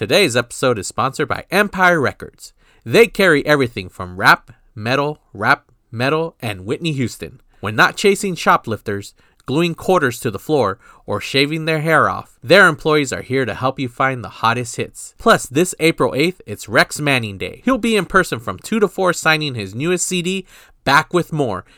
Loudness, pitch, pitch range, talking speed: -17 LUFS, 145 Hz, 120-175 Hz, 180 wpm